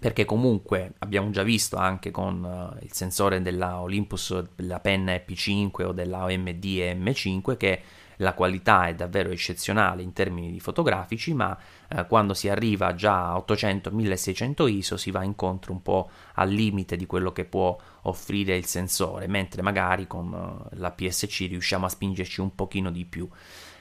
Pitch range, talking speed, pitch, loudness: 90-100 Hz, 155 wpm, 95 Hz, -26 LUFS